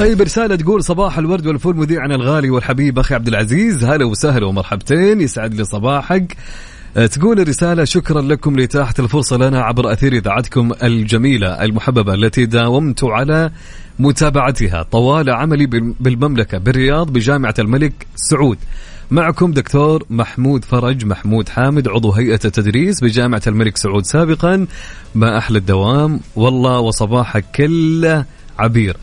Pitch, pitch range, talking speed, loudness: 130 Hz, 115-150 Hz, 125 wpm, -14 LUFS